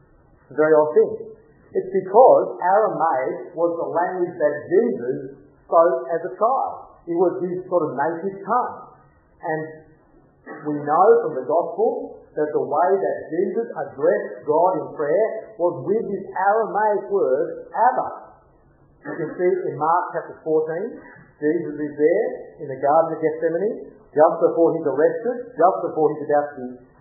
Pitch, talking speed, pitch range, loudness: 170 Hz, 155 wpm, 155-245 Hz, -21 LUFS